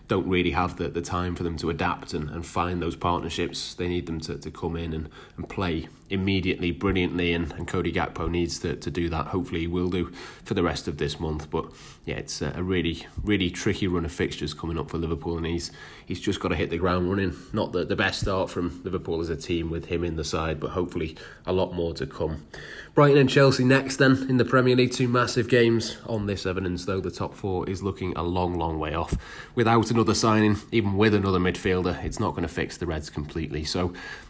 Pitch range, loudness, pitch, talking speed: 85-100 Hz, -26 LUFS, 90 Hz, 235 wpm